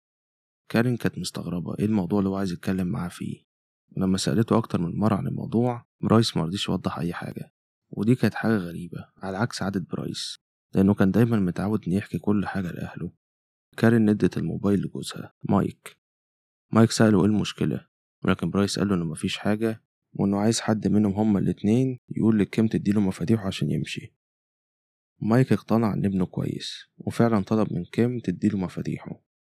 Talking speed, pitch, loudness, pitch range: 160 wpm, 105 Hz, -25 LUFS, 95-110 Hz